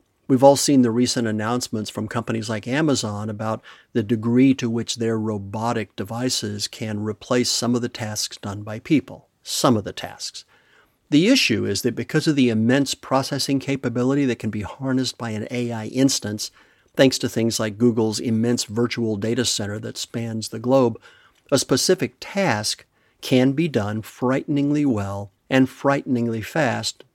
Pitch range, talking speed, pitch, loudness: 110-130 Hz, 160 wpm, 120 Hz, -22 LUFS